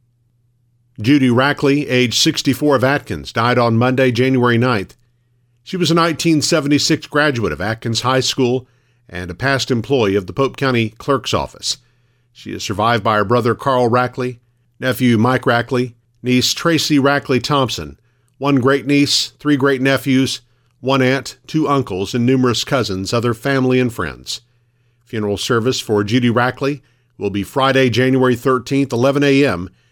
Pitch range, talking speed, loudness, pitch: 120-135 Hz, 150 wpm, -16 LUFS, 125 Hz